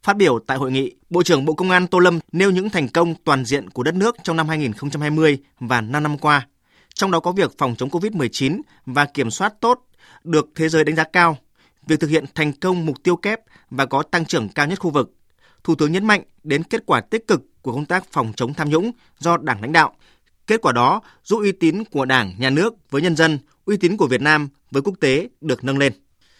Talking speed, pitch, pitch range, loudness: 240 wpm, 155 Hz, 140-180 Hz, -19 LUFS